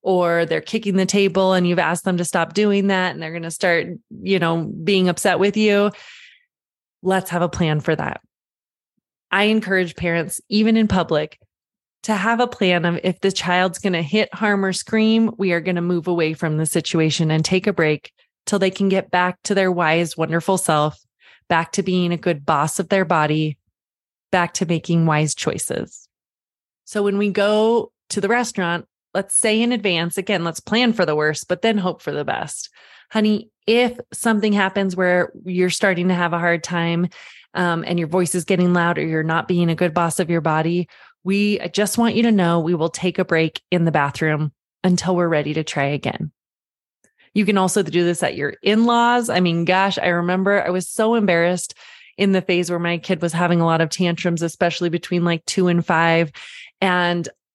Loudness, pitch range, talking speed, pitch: -19 LUFS, 170-200 Hz, 200 wpm, 180 Hz